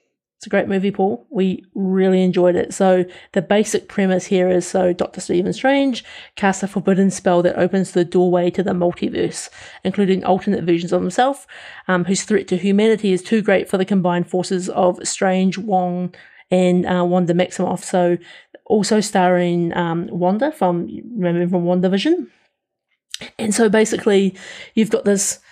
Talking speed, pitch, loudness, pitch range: 160 wpm, 190 Hz, -18 LUFS, 180-200 Hz